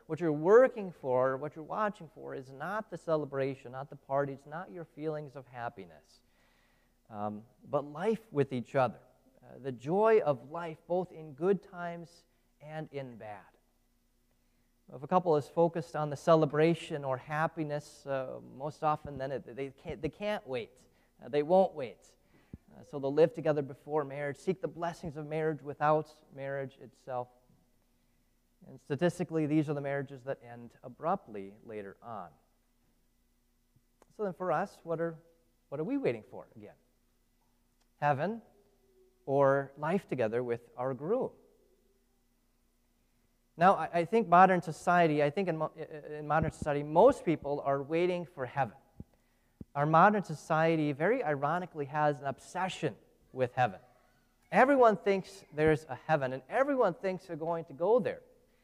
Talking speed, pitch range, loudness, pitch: 150 wpm, 135-170 Hz, -32 LUFS, 150 Hz